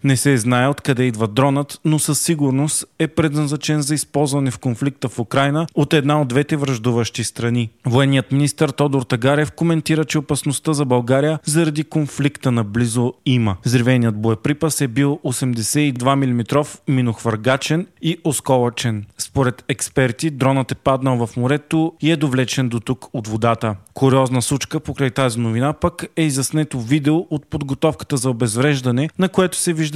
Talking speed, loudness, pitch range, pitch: 155 wpm, -18 LUFS, 125-150 Hz, 140 Hz